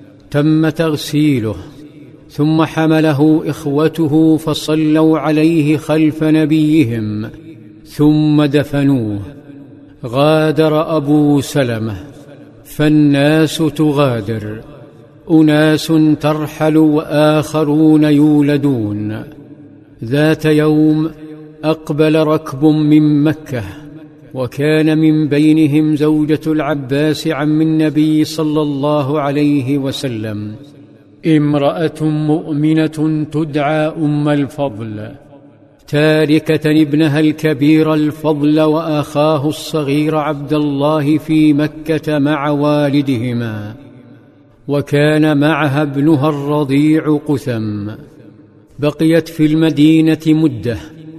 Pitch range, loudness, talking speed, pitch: 145-155 Hz, -13 LUFS, 75 wpm, 150 Hz